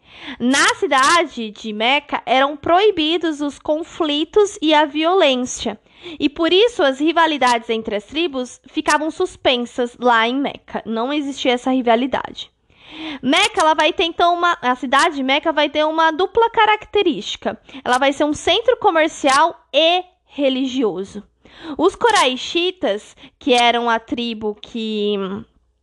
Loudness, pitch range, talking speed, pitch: -17 LUFS, 250-335 Hz, 135 wpm, 295 Hz